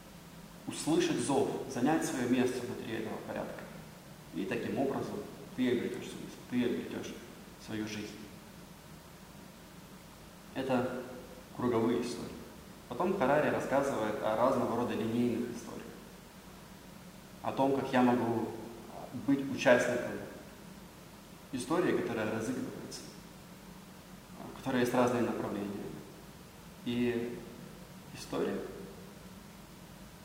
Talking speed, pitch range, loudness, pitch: 95 wpm, 120-190 Hz, -34 LUFS, 125 Hz